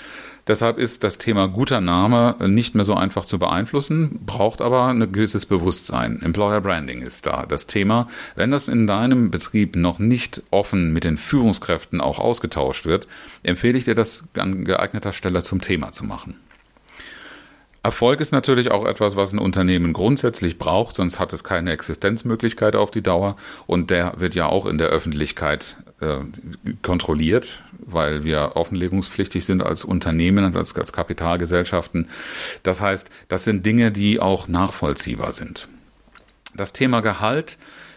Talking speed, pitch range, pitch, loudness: 155 wpm, 90-115 Hz, 100 Hz, -20 LUFS